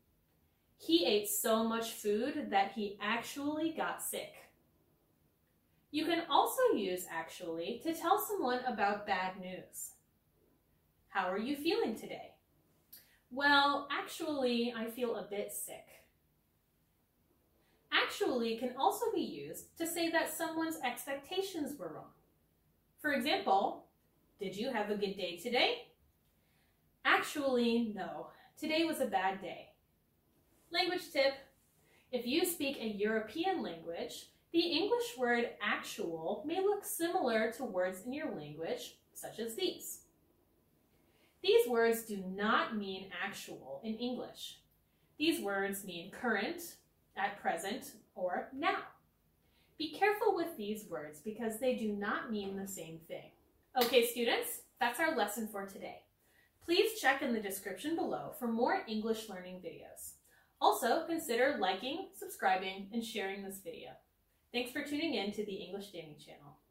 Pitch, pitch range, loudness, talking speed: 245 Hz, 200-320 Hz, -35 LUFS, 135 wpm